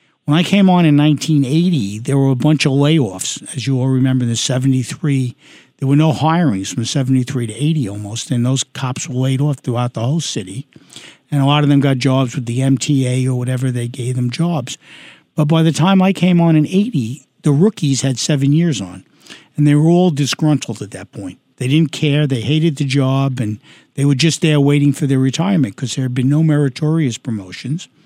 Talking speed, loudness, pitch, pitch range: 215 wpm, -15 LUFS, 140 Hz, 130-155 Hz